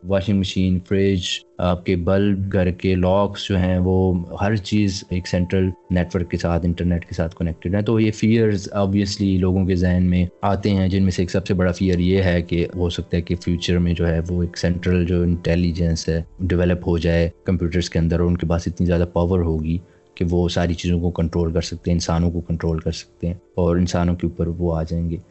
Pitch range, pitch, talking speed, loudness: 85-95 Hz, 90 Hz, 230 wpm, -20 LUFS